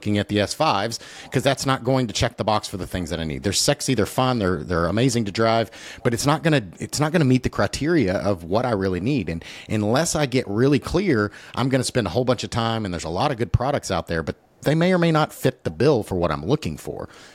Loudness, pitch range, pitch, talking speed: -22 LUFS, 100-135 Hz, 115 Hz, 285 wpm